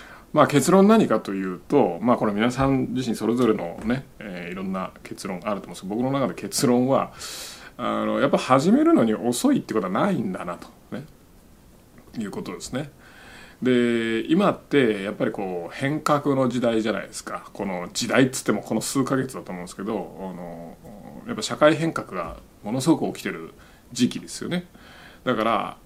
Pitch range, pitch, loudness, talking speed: 110-140 Hz, 125 Hz, -23 LUFS, 360 characters per minute